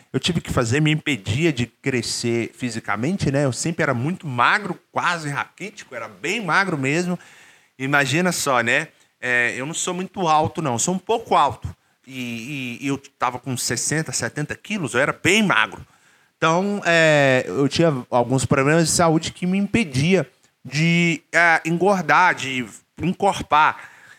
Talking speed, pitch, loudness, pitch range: 160 wpm, 145 Hz, -20 LUFS, 130-170 Hz